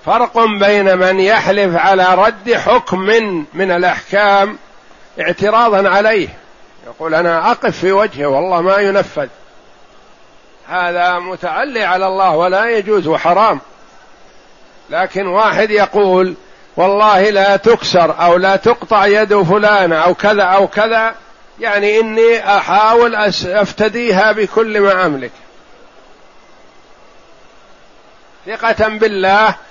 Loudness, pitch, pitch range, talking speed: -12 LUFS, 200 Hz, 185-215 Hz, 100 wpm